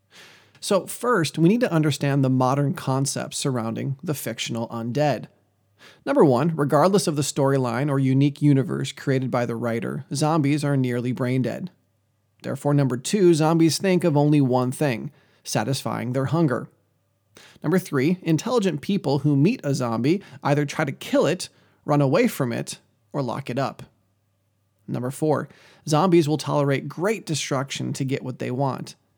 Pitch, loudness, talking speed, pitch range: 140 Hz, -23 LUFS, 155 wpm, 125-155 Hz